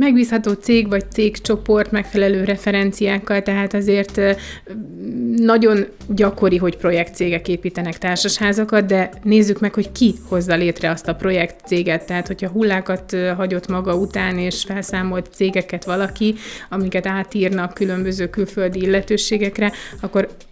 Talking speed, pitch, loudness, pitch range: 115 wpm, 195 Hz, -18 LUFS, 185-210 Hz